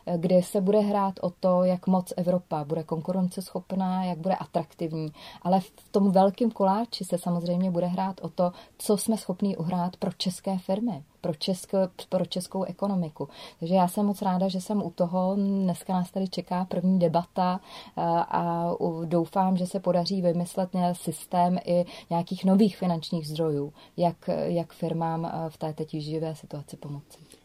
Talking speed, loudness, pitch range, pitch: 160 wpm, -27 LUFS, 170-190 Hz, 180 Hz